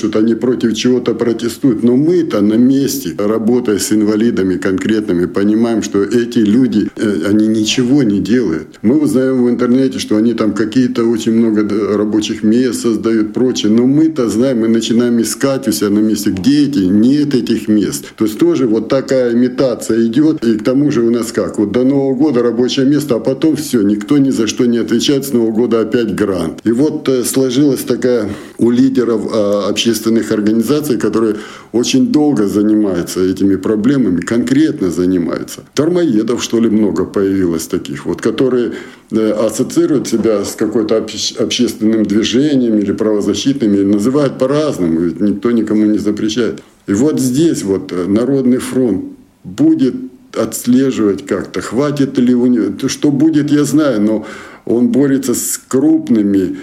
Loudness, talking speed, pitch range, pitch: -13 LUFS, 155 wpm, 105-130 Hz, 115 Hz